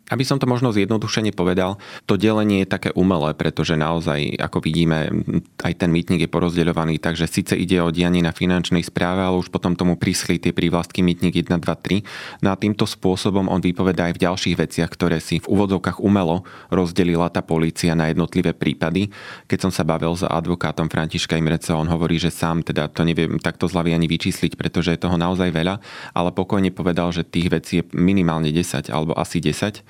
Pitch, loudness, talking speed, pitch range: 85 Hz, -20 LUFS, 195 wpm, 85-95 Hz